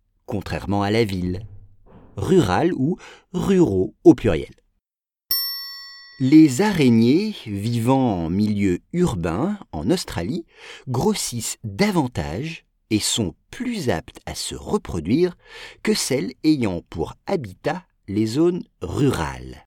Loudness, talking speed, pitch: -21 LUFS, 105 wpm, 135 Hz